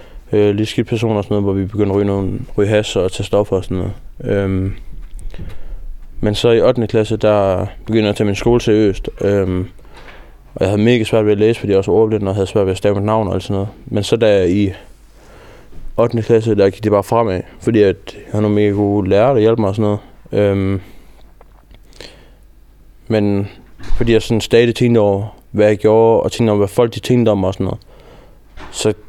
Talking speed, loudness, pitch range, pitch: 215 wpm, -15 LUFS, 100-110 Hz, 105 Hz